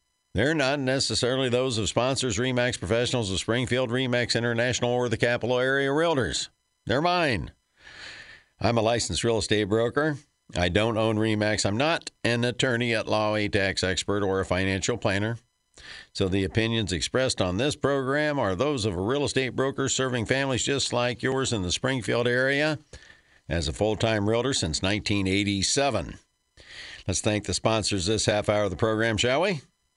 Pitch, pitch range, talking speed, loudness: 115 Hz, 105-130 Hz, 170 wpm, -25 LUFS